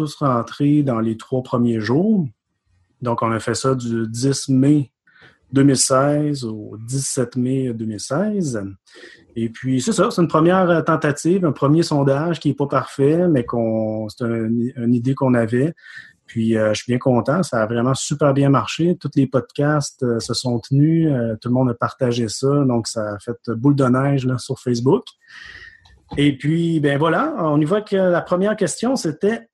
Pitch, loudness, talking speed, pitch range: 135 Hz, -19 LUFS, 185 wpm, 120-155 Hz